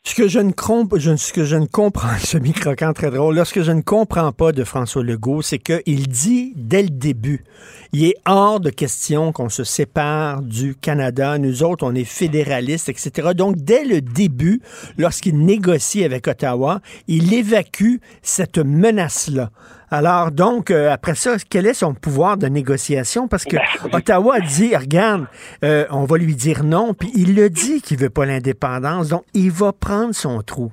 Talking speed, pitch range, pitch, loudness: 180 wpm, 145-195 Hz, 160 Hz, -17 LUFS